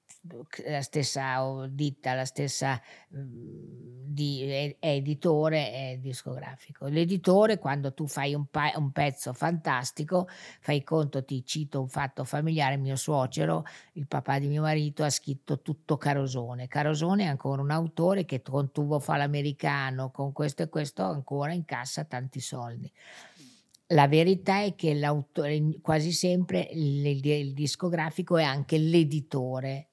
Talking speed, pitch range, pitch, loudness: 135 wpm, 135-155 Hz, 145 Hz, -29 LUFS